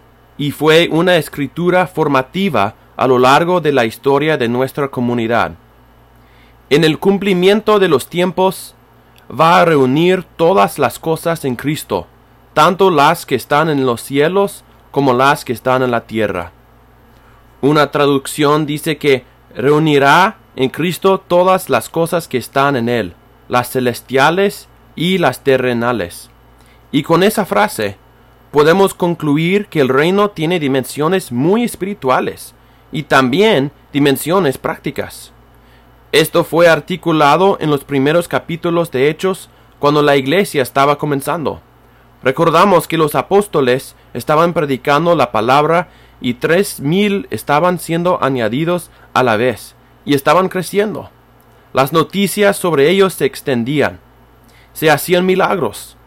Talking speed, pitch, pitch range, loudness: 130 wpm, 145 Hz, 130-175 Hz, -14 LUFS